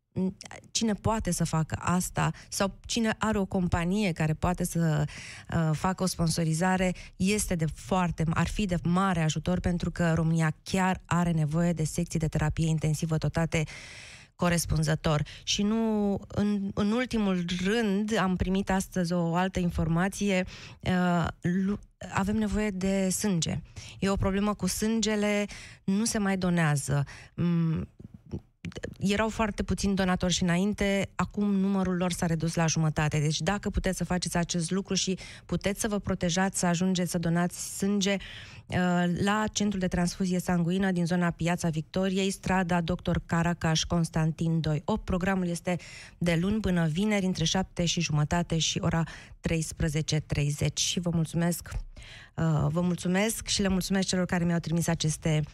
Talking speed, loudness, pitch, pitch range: 150 wpm, -28 LUFS, 175 Hz, 165-195 Hz